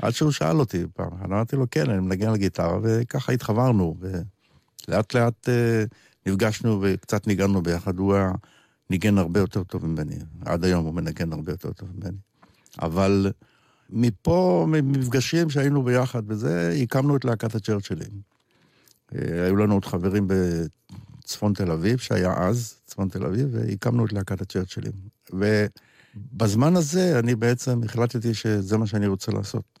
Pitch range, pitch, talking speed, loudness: 95-120 Hz, 105 Hz, 145 wpm, -24 LUFS